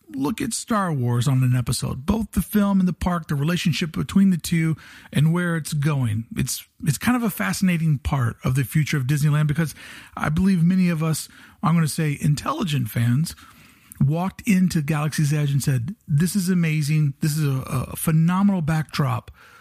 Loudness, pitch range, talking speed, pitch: -22 LUFS, 145-185 Hz, 185 wpm, 160 Hz